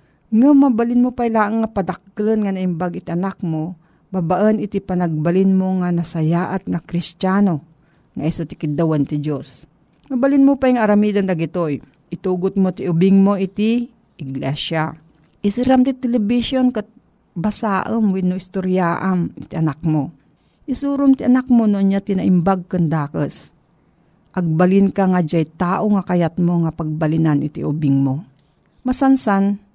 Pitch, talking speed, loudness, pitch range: 185 Hz, 145 wpm, -18 LUFS, 165-210 Hz